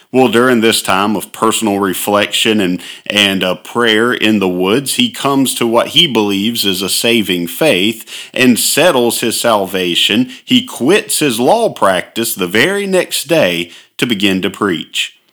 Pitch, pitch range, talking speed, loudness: 110 Hz, 95-120 Hz, 160 wpm, -12 LUFS